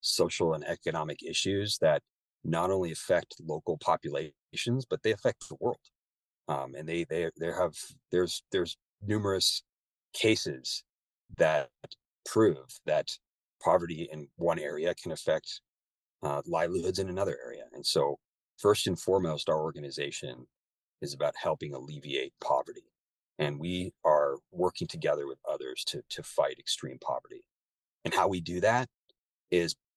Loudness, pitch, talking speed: -31 LUFS, 95 Hz, 140 wpm